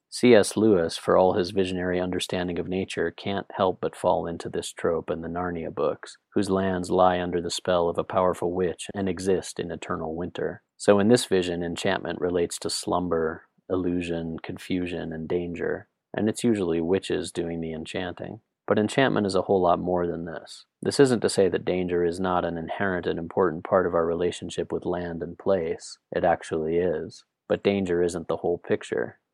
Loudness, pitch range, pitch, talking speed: -26 LUFS, 85-95 Hz, 90 Hz, 190 wpm